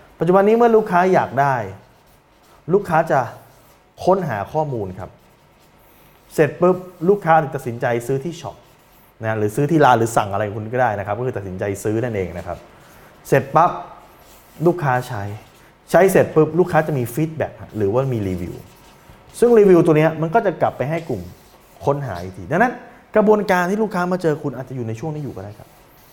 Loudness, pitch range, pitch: -18 LUFS, 110-175 Hz, 140 Hz